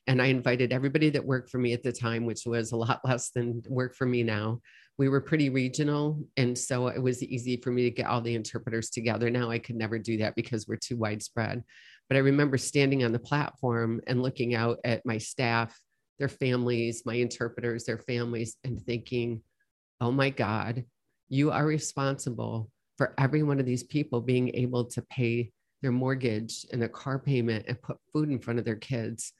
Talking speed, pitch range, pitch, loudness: 200 wpm, 115-130 Hz, 120 Hz, -30 LUFS